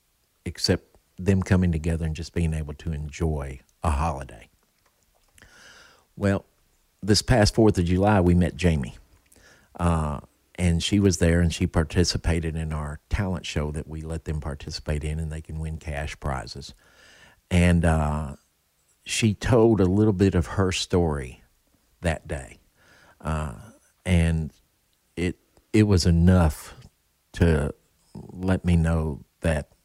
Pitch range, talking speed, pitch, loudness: 75-90 Hz, 135 wpm, 85 Hz, -24 LUFS